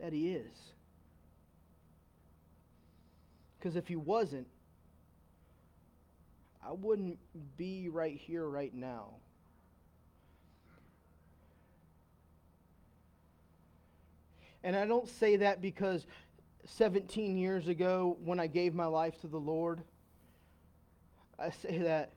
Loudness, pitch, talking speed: -36 LUFS, 85 Hz, 90 wpm